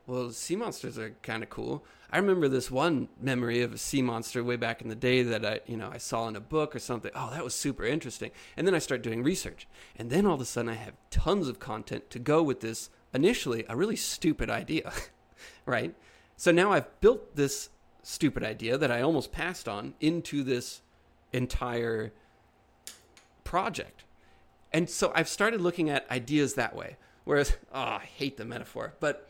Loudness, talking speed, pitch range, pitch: -30 LUFS, 195 wpm, 115-150 Hz, 125 Hz